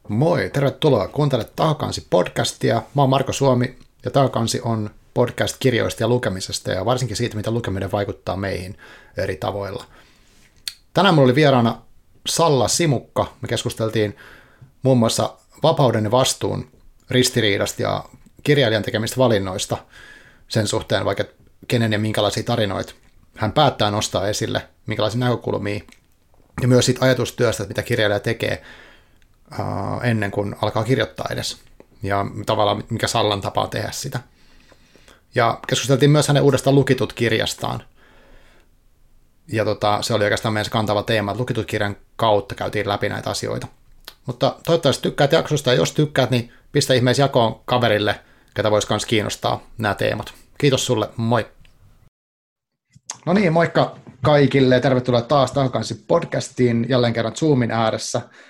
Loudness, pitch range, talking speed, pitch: -20 LUFS, 105-130 Hz, 130 wpm, 120 Hz